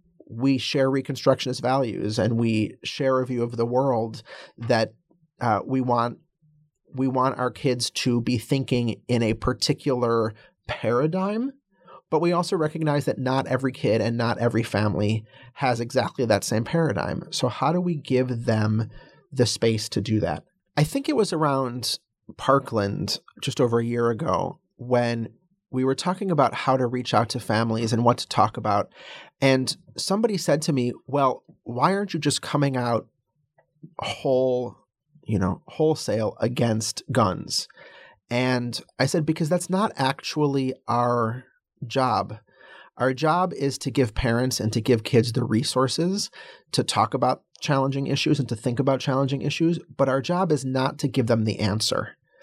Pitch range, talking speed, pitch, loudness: 115-150 Hz, 160 wpm, 130 Hz, -24 LUFS